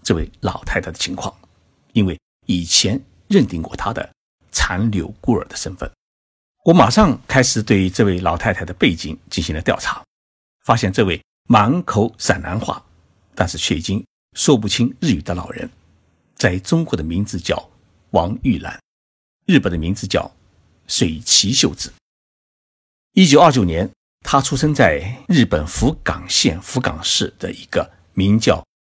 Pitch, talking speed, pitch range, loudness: 100 Hz, 225 characters per minute, 90-120 Hz, -17 LUFS